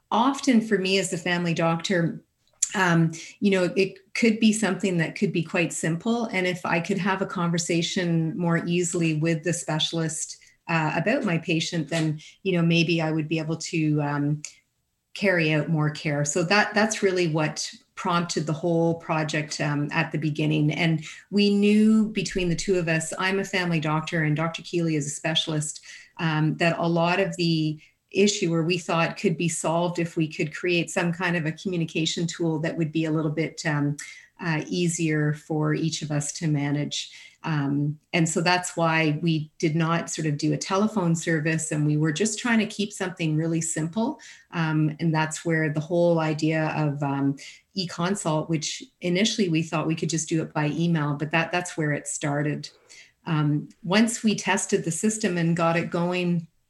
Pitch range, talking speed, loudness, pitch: 155-185 Hz, 190 wpm, -25 LUFS, 165 Hz